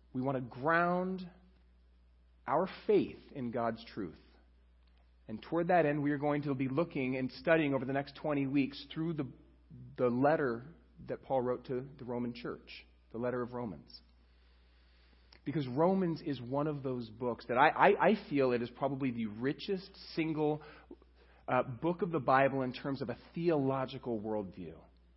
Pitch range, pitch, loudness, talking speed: 105-145 Hz, 130 Hz, -34 LUFS, 165 wpm